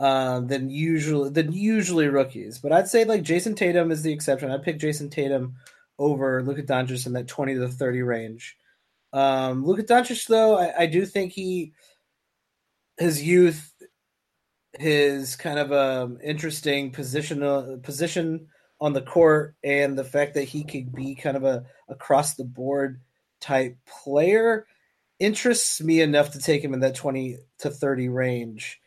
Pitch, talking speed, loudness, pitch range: 145 Hz, 165 wpm, -24 LUFS, 135-160 Hz